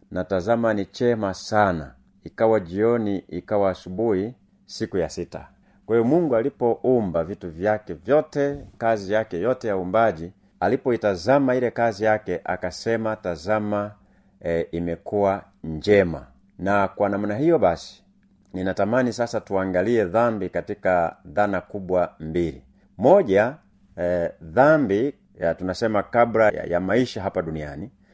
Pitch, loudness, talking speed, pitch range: 100 Hz, -23 LUFS, 115 wpm, 90-115 Hz